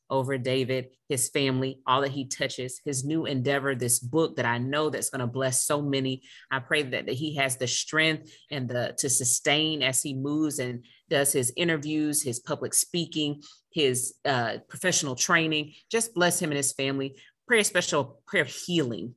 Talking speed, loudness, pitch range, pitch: 190 wpm, -26 LUFS, 130-155 Hz, 140 Hz